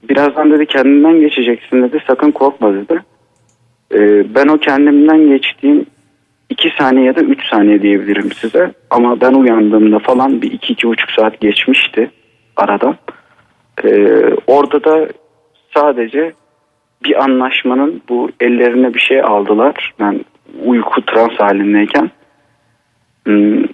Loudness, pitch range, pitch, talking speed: -11 LUFS, 115-150 Hz, 130 Hz, 125 wpm